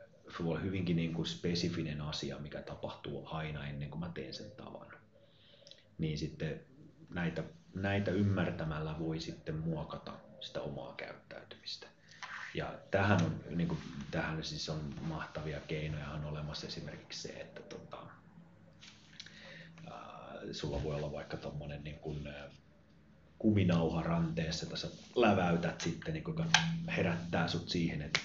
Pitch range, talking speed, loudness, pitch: 75-100 Hz, 130 wpm, -37 LUFS, 85 Hz